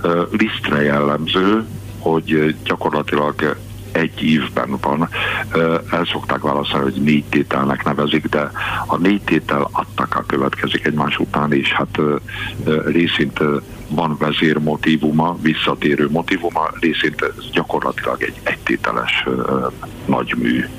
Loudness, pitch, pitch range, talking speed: -18 LUFS, 80 Hz, 75-85 Hz, 105 wpm